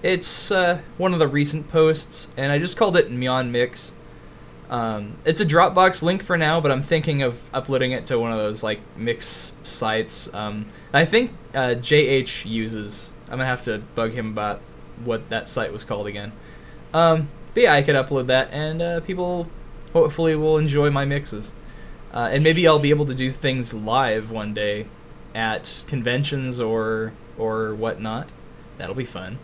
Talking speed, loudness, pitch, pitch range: 180 wpm, -22 LUFS, 130 Hz, 110-155 Hz